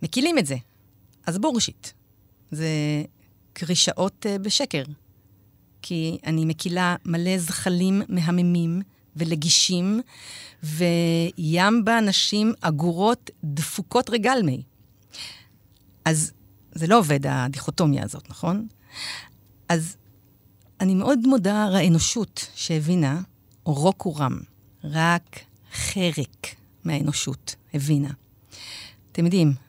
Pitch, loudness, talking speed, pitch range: 160 Hz, -23 LUFS, 85 wpm, 125-185 Hz